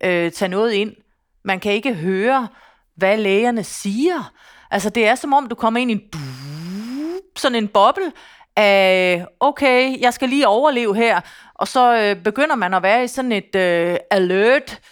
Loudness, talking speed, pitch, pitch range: -17 LUFS, 170 wpm, 215 Hz, 195-255 Hz